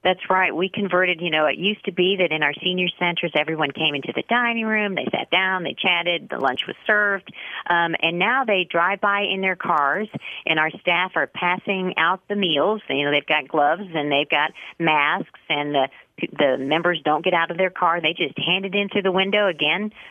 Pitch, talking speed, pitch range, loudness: 180 Hz, 225 wpm, 155-195 Hz, -21 LUFS